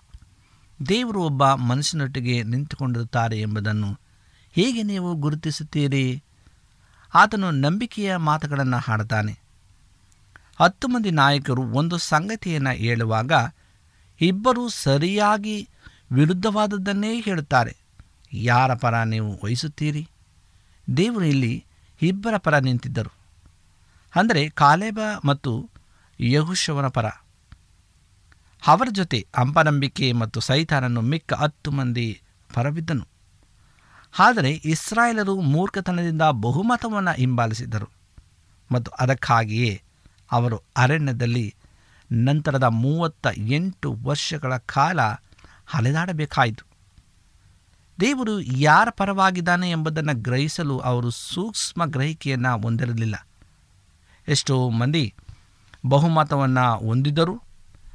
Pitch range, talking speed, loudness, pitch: 105-155 Hz, 75 wpm, -22 LUFS, 130 Hz